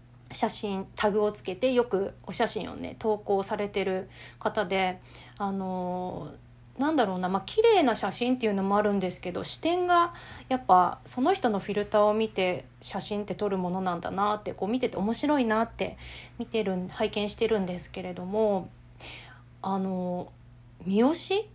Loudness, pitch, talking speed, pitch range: -28 LUFS, 200 Hz, 320 characters per minute, 185-225 Hz